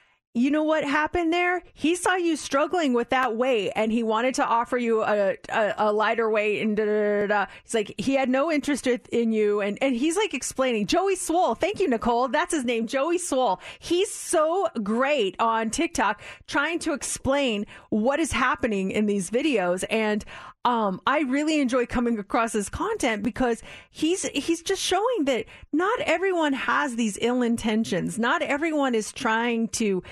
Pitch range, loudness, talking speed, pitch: 220-310 Hz, -24 LUFS, 180 wpm, 255 Hz